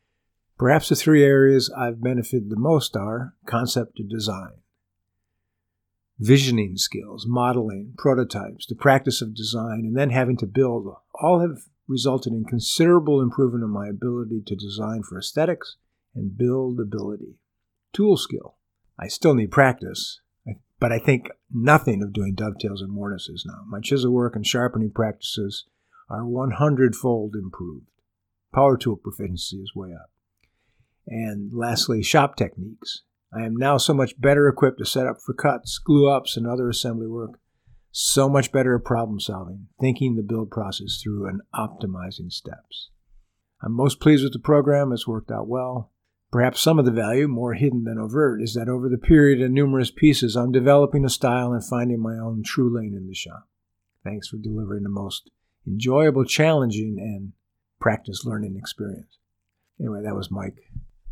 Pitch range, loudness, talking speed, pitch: 100-130 Hz, -22 LUFS, 160 wpm, 115 Hz